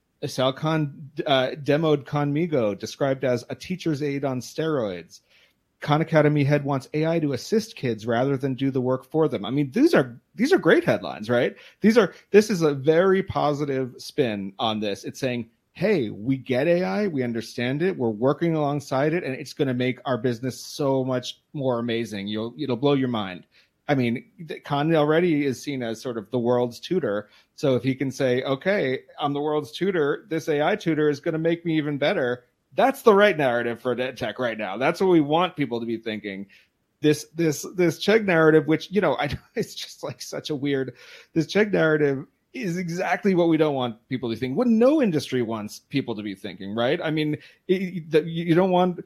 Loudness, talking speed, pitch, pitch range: -24 LUFS, 205 wpm, 145 Hz, 125-160 Hz